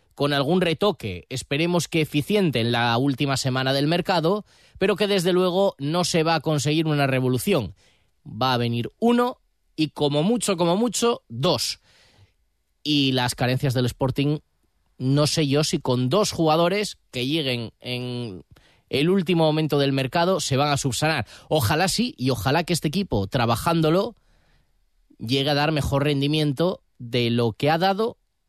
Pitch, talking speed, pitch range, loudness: 145 Hz, 160 wpm, 125-175 Hz, -22 LUFS